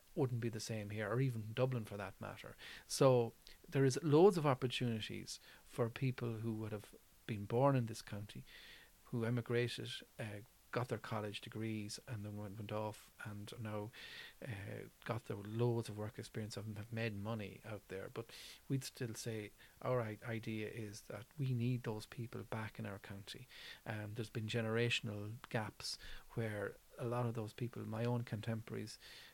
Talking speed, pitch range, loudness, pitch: 170 wpm, 105-120 Hz, -41 LUFS, 115 Hz